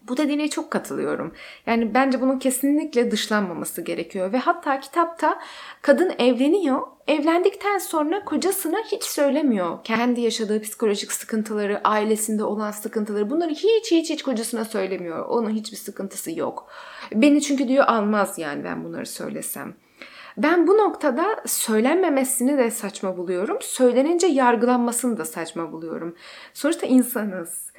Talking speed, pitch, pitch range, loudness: 125 wpm, 250 Hz, 215-300 Hz, -22 LUFS